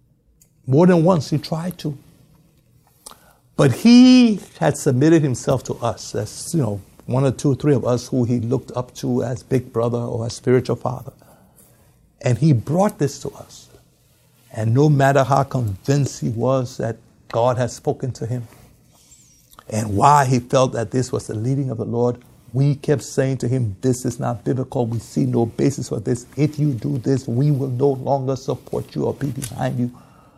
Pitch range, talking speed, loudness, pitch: 120-145 Hz, 190 wpm, -19 LUFS, 130 Hz